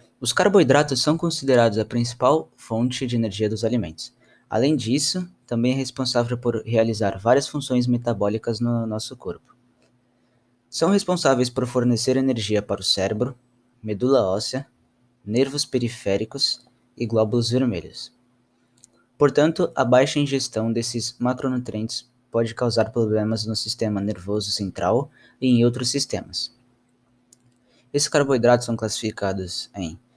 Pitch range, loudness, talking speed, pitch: 110-130 Hz, -22 LUFS, 120 wpm, 120 Hz